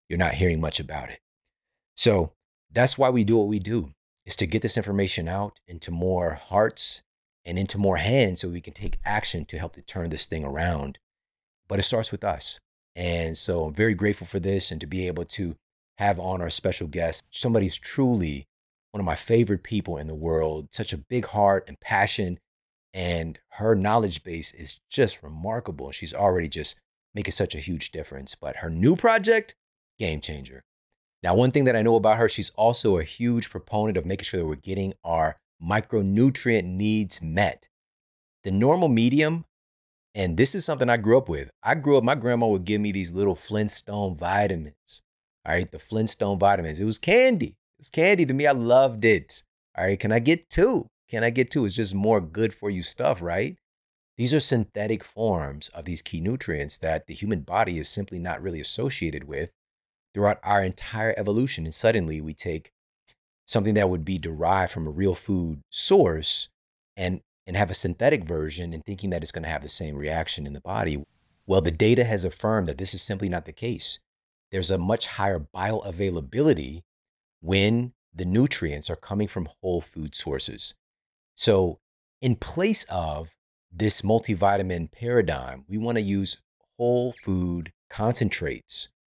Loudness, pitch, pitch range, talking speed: -24 LUFS, 95 Hz, 85-110 Hz, 185 wpm